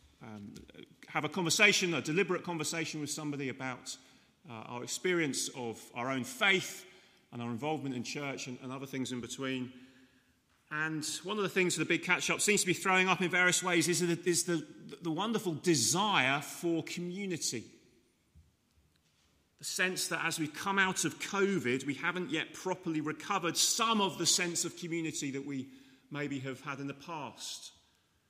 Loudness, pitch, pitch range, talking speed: -32 LUFS, 155 Hz, 130-180 Hz, 175 wpm